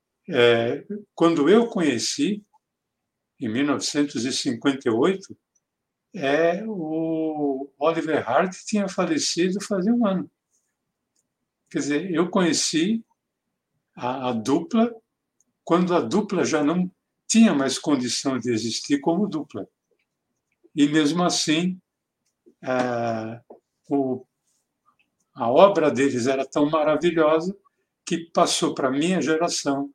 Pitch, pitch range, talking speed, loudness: 160 Hz, 140-185 Hz, 100 wpm, -22 LUFS